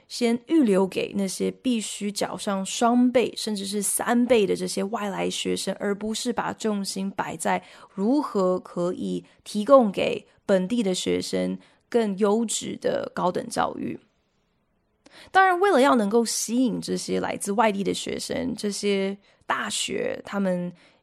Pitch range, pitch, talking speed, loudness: 185-235 Hz, 205 Hz, 215 characters per minute, -24 LUFS